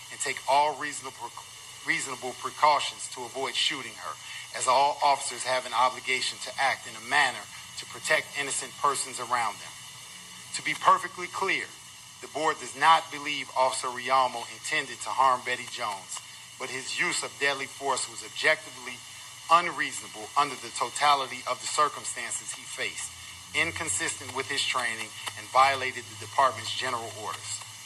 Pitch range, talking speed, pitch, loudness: 115-140 Hz, 150 wpm, 130 Hz, -28 LUFS